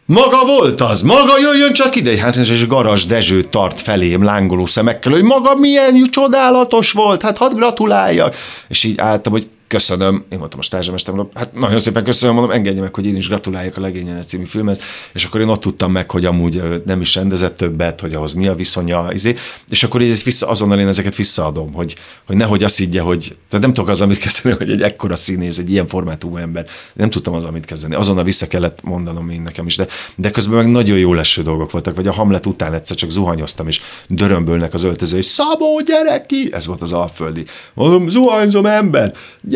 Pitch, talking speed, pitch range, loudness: 100 Hz, 205 wpm, 90-120 Hz, -13 LUFS